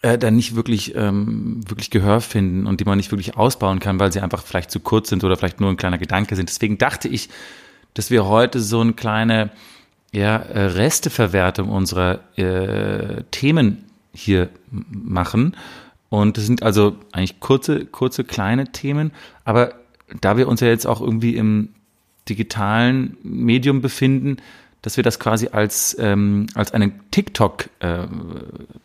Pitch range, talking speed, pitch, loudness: 100-115 Hz, 155 wpm, 110 Hz, -19 LUFS